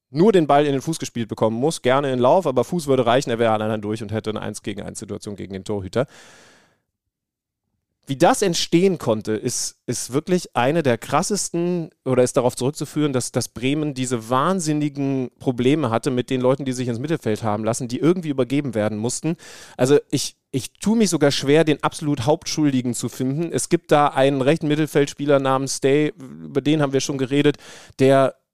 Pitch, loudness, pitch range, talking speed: 135 Hz, -20 LUFS, 120-150 Hz, 195 wpm